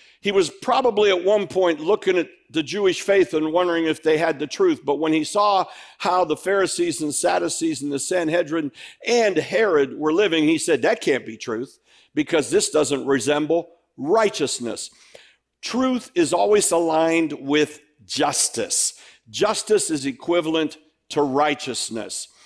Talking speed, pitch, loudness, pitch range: 150 wpm, 175 Hz, -21 LUFS, 155-215 Hz